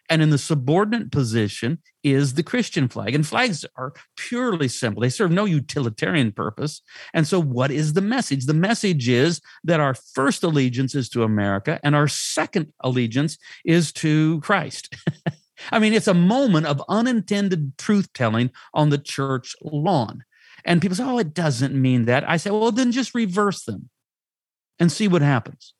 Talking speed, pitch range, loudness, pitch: 170 wpm, 135-195 Hz, -21 LUFS, 155 Hz